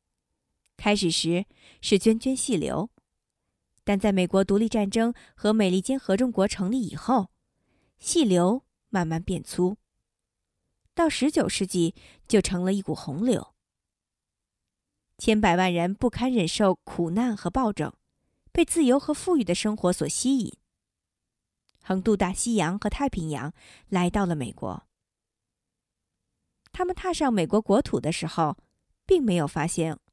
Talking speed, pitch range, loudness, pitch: 200 characters per minute, 175-245 Hz, -25 LUFS, 200 Hz